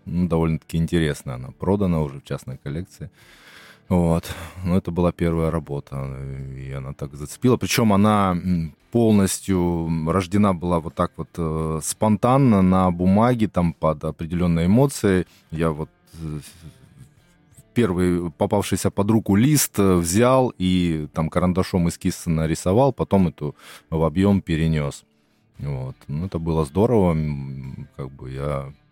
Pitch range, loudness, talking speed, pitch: 80-100 Hz, -21 LUFS, 130 wpm, 85 Hz